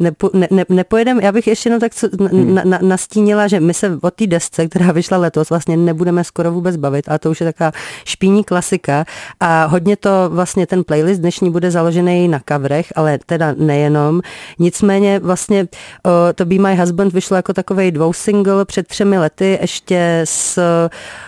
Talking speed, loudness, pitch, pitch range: 180 wpm, -14 LUFS, 180 Hz, 170-195 Hz